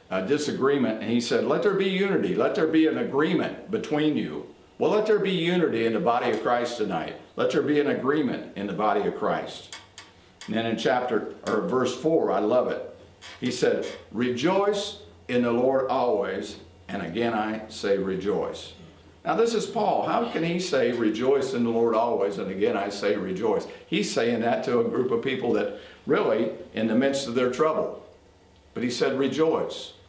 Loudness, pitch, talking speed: -25 LUFS, 145 Hz, 195 wpm